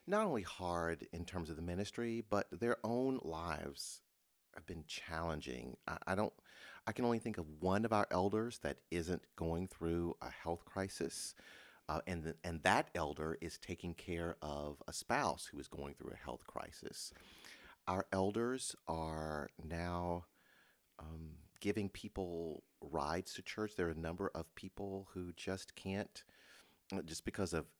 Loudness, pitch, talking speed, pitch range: -42 LUFS, 90 Hz, 160 wpm, 80-100 Hz